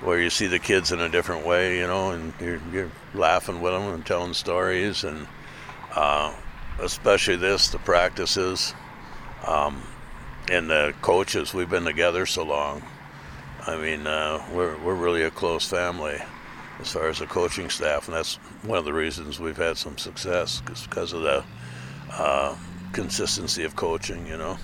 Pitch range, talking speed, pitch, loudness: 75-90 Hz, 170 wpm, 85 Hz, -25 LUFS